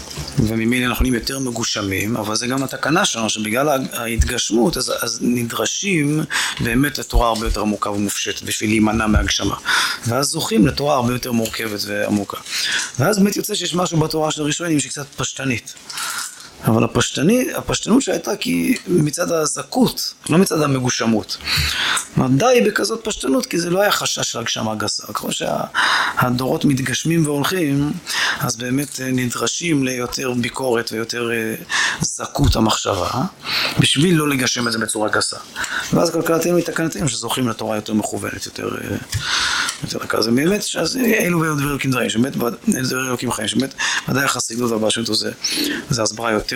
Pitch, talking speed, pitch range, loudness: 130 Hz, 135 wpm, 115-160 Hz, -19 LUFS